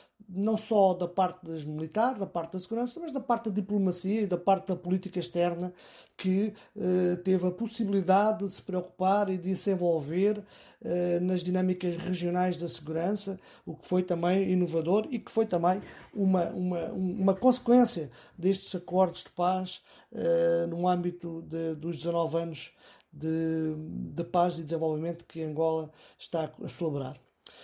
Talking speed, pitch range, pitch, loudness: 155 wpm, 170-195 Hz, 180 Hz, -30 LUFS